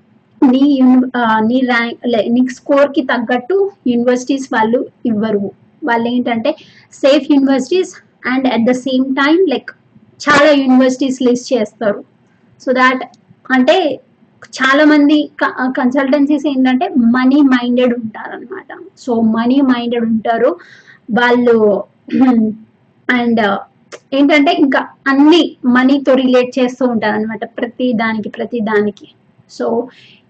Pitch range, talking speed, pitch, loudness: 235-285 Hz, 105 wpm, 255 Hz, -13 LUFS